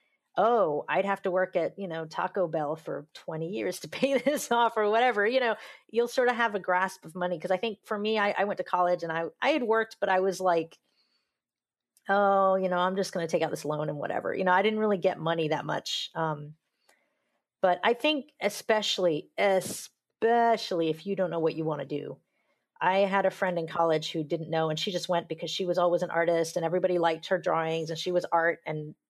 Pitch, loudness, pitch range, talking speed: 185 Hz, -28 LUFS, 165-205 Hz, 235 wpm